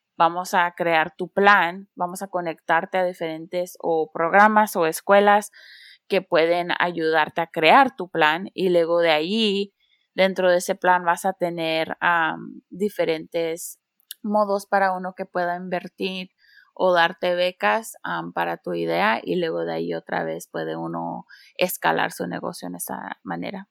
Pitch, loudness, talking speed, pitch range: 175 Hz, -22 LUFS, 155 wpm, 160-190 Hz